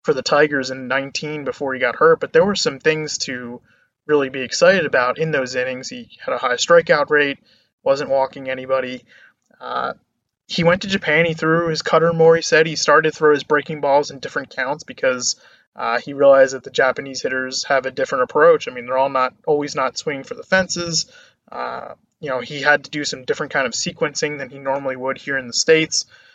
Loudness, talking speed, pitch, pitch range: -18 LUFS, 220 wpm, 145 Hz, 135-160 Hz